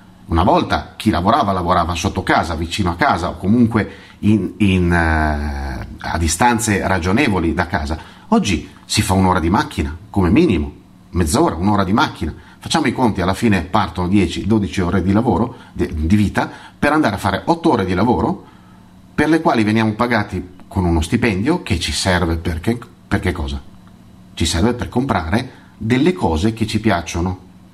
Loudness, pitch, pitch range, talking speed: -17 LUFS, 95 Hz, 85-110 Hz, 170 wpm